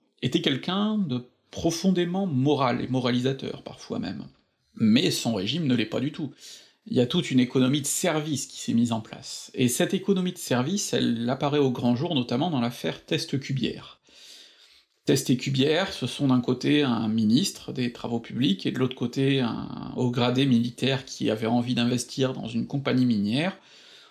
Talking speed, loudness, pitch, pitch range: 180 wpm, -26 LUFS, 130 Hz, 120-150 Hz